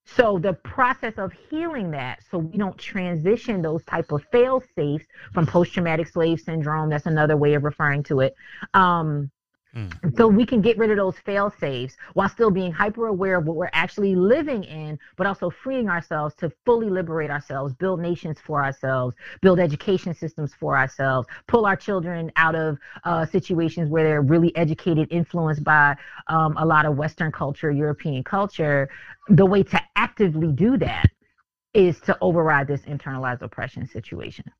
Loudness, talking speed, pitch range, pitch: -22 LUFS, 170 wpm, 150-195 Hz, 165 Hz